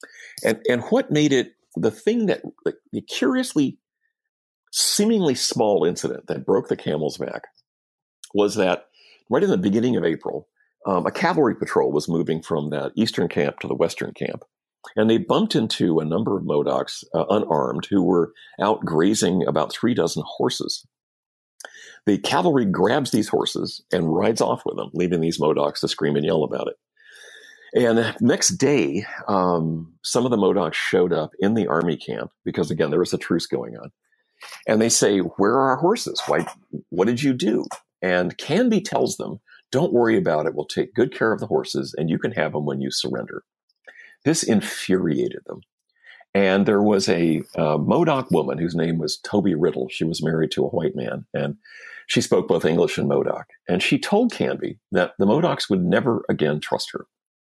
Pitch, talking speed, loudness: 115 Hz, 185 wpm, -22 LUFS